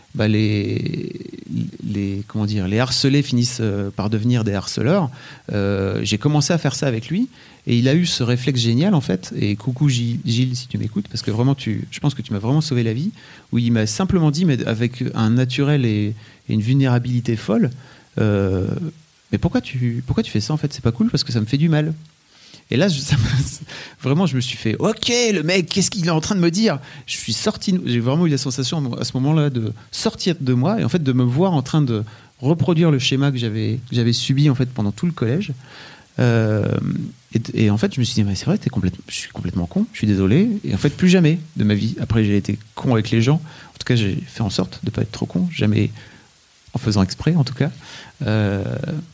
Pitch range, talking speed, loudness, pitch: 110-155 Hz, 240 wpm, -20 LUFS, 130 Hz